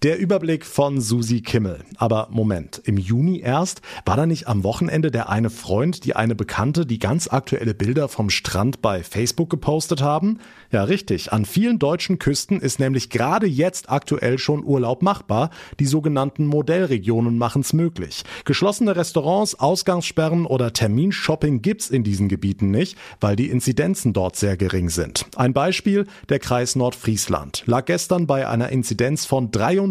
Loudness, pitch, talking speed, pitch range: -21 LUFS, 135 Hz, 160 wpm, 115-165 Hz